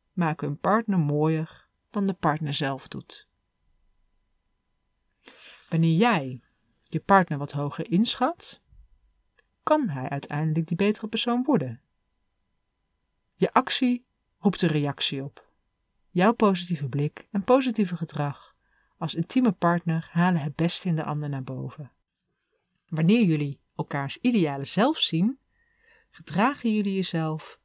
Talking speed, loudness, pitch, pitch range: 120 wpm, -25 LUFS, 165 Hz, 145-210 Hz